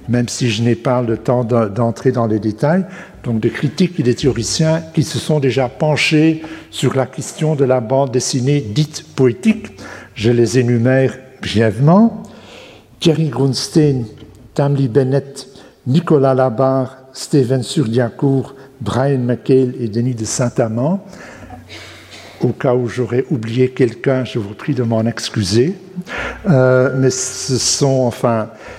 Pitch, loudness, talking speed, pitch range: 130 Hz, -16 LUFS, 140 wpm, 120-145 Hz